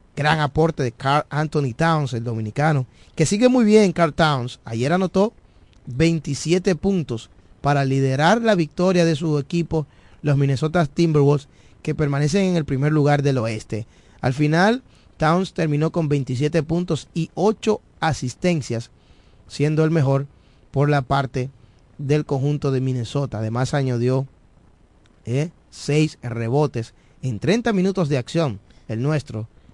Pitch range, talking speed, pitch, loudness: 125-165 Hz, 135 wpm, 145 Hz, -21 LUFS